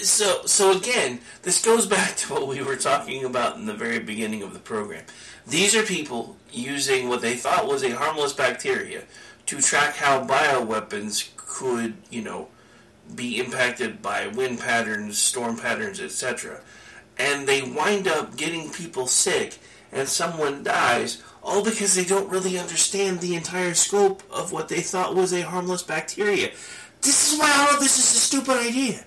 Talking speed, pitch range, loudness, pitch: 170 wpm, 135-225 Hz, -22 LUFS, 180 Hz